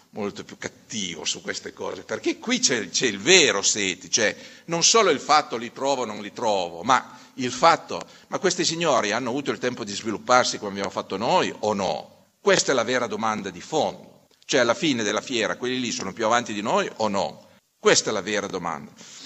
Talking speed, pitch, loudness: 210 wpm, 150 Hz, -23 LUFS